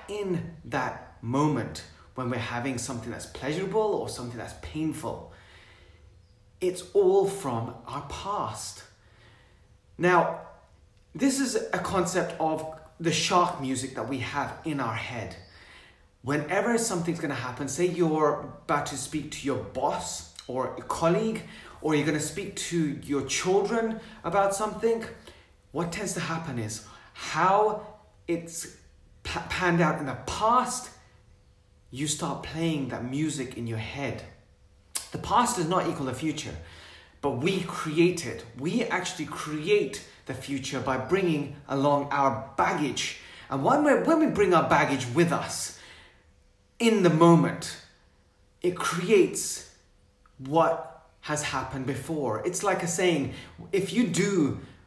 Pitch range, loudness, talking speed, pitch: 115-175 Hz, -28 LUFS, 140 wpm, 145 Hz